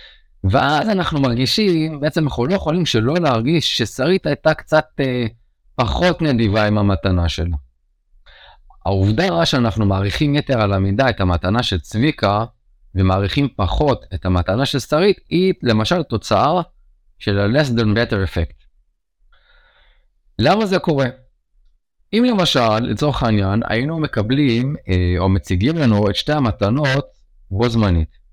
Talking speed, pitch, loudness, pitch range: 125 wpm, 115 Hz, -18 LUFS, 95-150 Hz